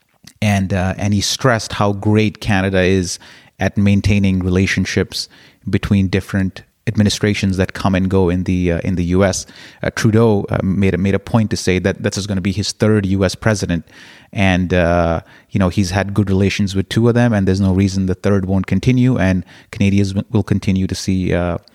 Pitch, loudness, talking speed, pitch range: 100 Hz, -16 LUFS, 200 wpm, 95-105 Hz